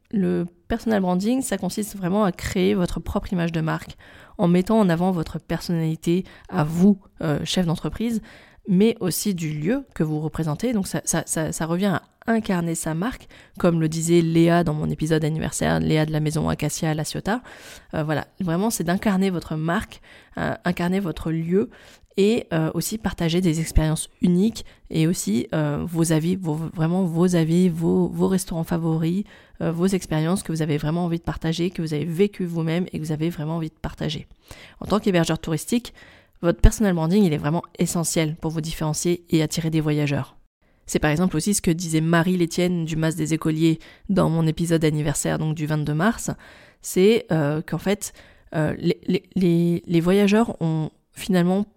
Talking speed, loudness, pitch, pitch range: 185 wpm, -23 LUFS, 170 Hz, 160-190 Hz